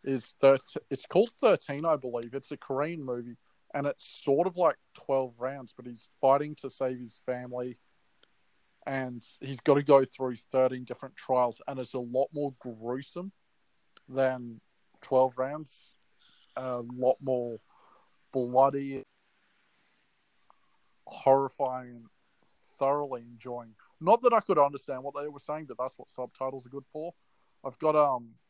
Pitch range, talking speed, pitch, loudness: 125-140 Hz, 145 wpm, 130 Hz, -30 LUFS